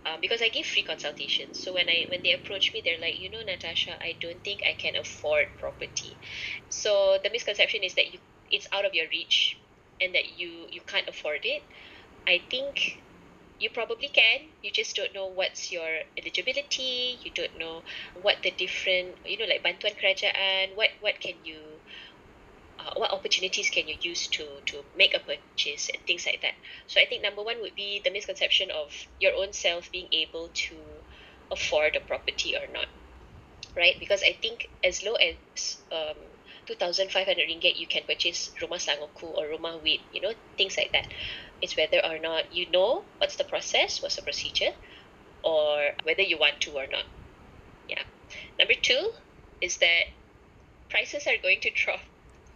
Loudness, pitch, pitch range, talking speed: -27 LUFS, 200 Hz, 175-290 Hz, 185 wpm